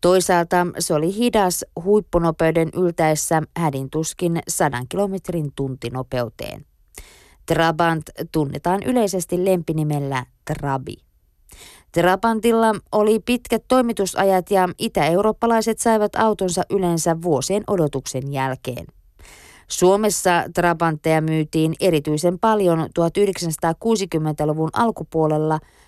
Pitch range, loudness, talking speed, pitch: 155-195 Hz, -20 LUFS, 80 wpm, 170 Hz